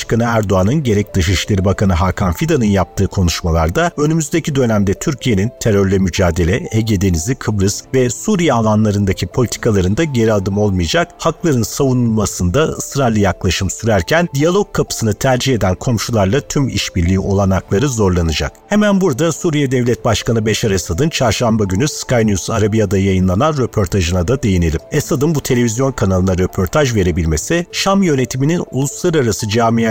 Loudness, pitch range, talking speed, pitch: -15 LUFS, 95-135 Hz, 125 wpm, 110 Hz